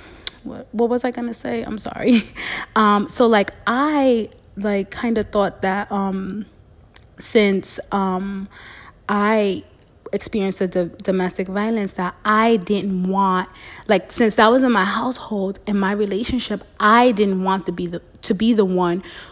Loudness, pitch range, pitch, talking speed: -20 LUFS, 190-230 Hz, 205 Hz, 155 wpm